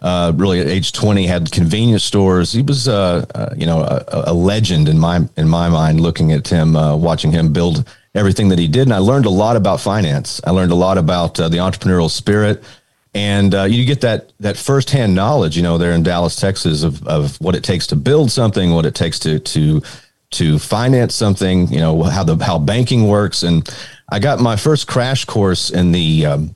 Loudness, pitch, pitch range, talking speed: -14 LUFS, 95 Hz, 85-110 Hz, 215 wpm